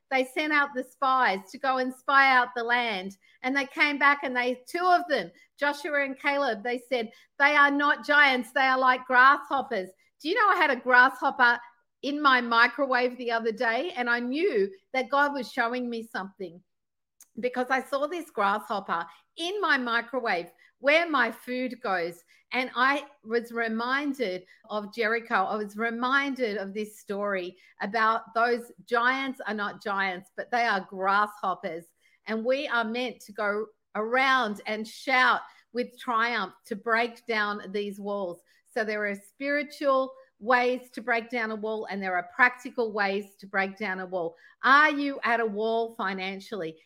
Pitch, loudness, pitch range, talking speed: 240 Hz, -26 LUFS, 210-270 Hz, 170 wpm